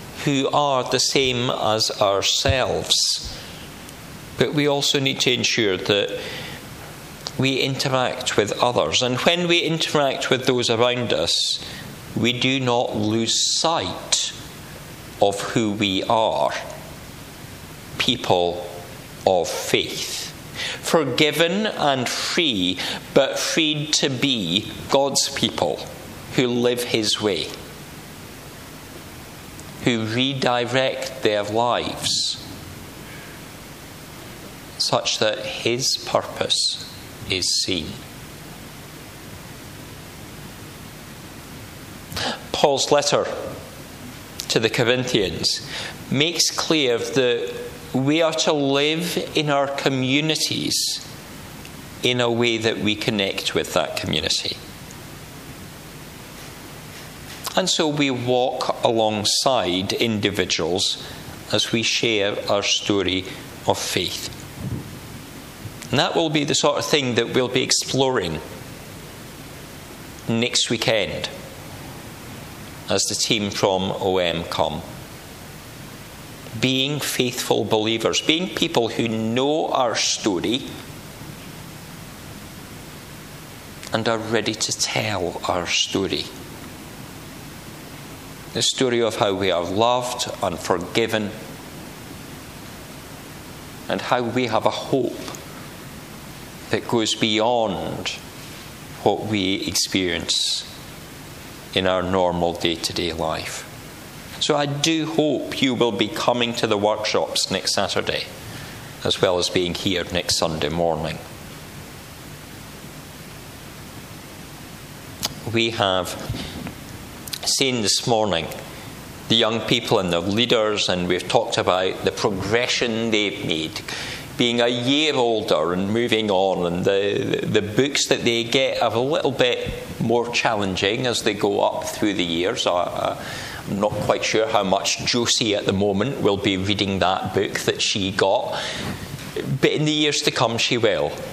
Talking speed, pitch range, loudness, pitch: 110 wpm, 105-135 Hz, -21 LUFS, 120 Hz